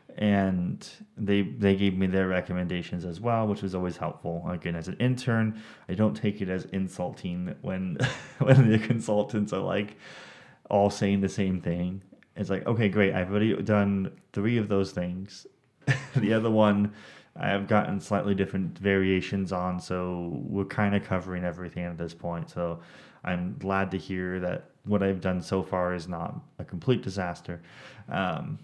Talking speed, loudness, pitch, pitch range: 170 wpm, -28 LUFS, 100 Hz, 90-110 Hz